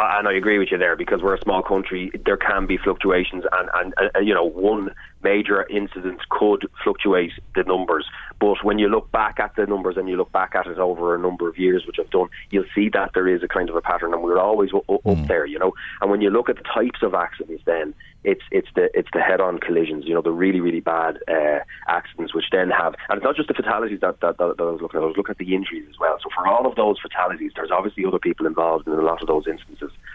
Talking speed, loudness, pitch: 275 wpm, -21 LUFS, 95 Hz